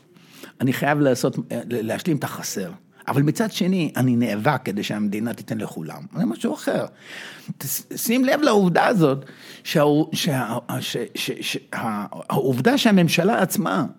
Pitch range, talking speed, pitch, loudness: 130-200 Hz, 110 wpm, 155 Hz, -22 LUFS